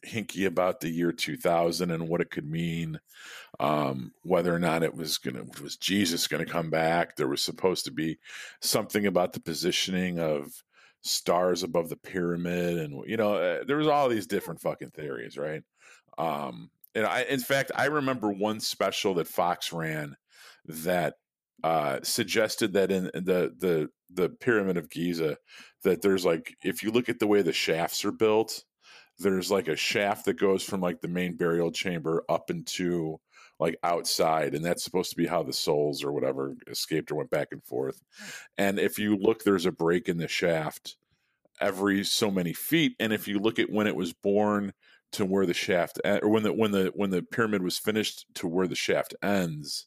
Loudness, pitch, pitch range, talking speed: -28 LUFS, 90 Hz, 85-105 Hz, 190 wpm